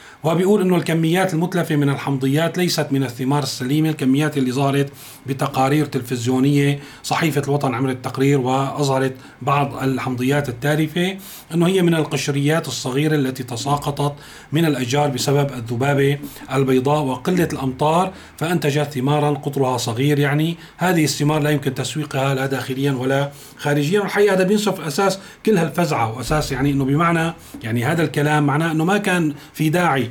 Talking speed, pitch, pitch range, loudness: 140 wpm, 145 Hz, 135-160 Hz, -19 LUFS